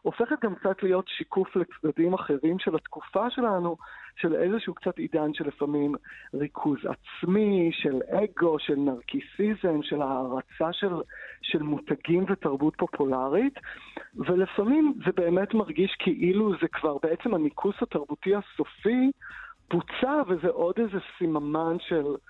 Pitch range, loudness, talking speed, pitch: 155-205 Hz, -27 LUFS, 125 wpm, 180 Hz